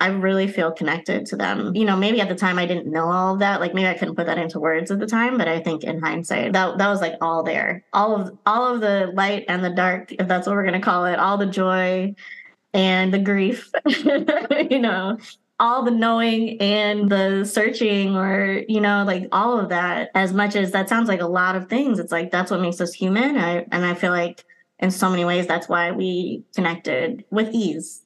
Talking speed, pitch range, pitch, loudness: 235 wpm, 180-215 Hz, 195 Hz, -21 LUFS